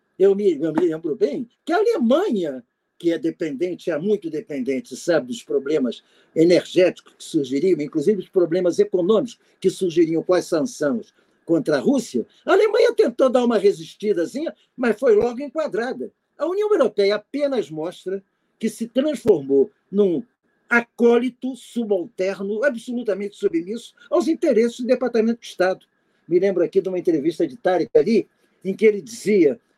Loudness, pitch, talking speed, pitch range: -21 LUFS, 215 Hz, 150 wpm, 185-270 Hz